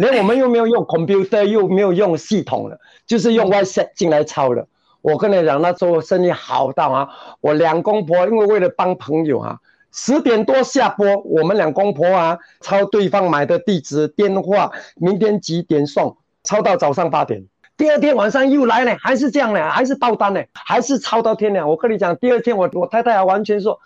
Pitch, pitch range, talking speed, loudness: 200 Hz, 170-230 Hz, 315 characters per minute, -16 LUFS